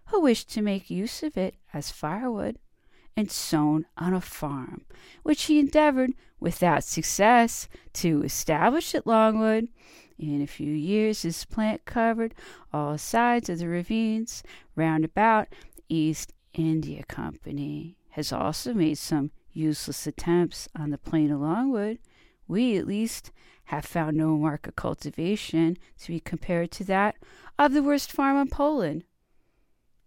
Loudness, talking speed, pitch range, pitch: -26 LUFS, 145 wpm, 155-230 Hz, 180 Hz